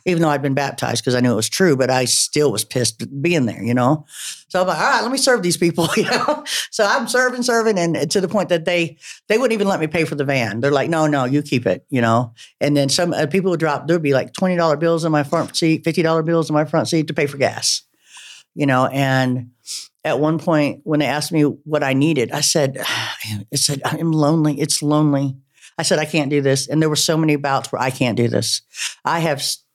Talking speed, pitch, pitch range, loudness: 260 wpm, 150 Hz, 135-165 Hz, -18 LUFS